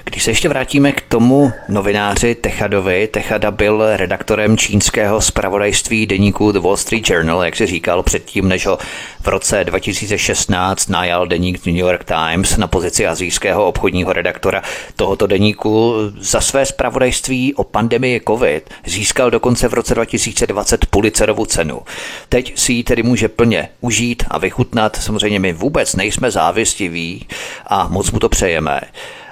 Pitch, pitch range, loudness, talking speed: 110 Hz, 95-120 Hz, -15 LUFS, 145 wpm